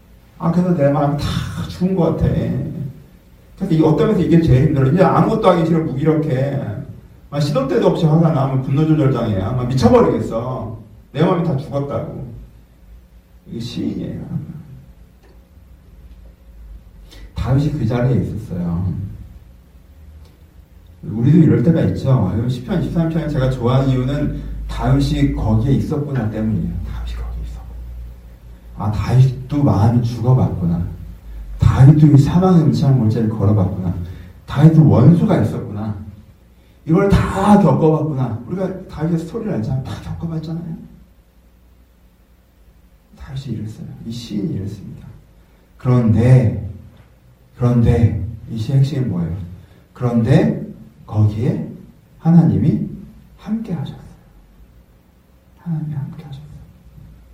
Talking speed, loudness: 260 characters per minute, -17 LUFS